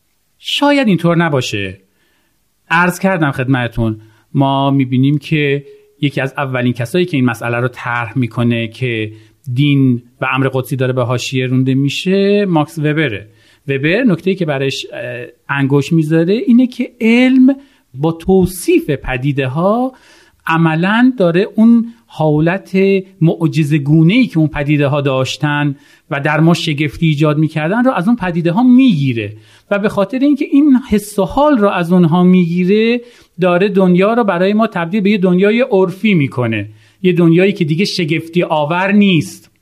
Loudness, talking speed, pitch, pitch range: -13 LUFS, 150 wpm, 165 Hz, 135-195 Hz